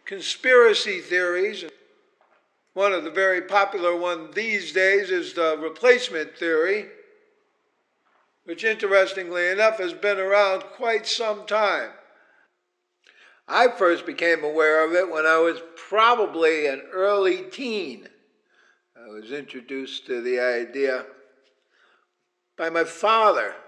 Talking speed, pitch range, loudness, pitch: 115 wpm, 165-225 Hz, -22 LUFS, 190 Hz